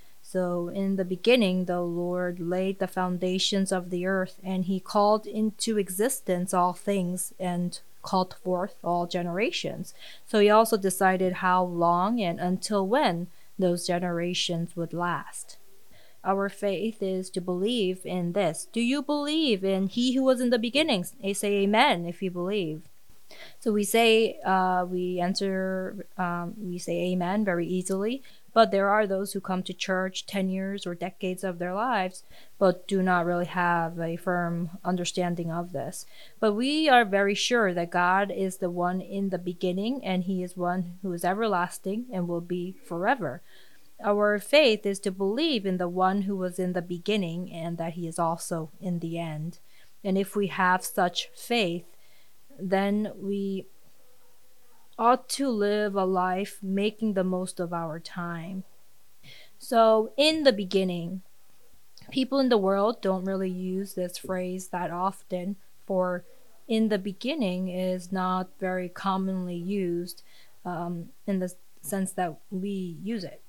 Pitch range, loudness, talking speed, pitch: 180-205 Hz, -27 LUFS, 160 wpm, 185 Hz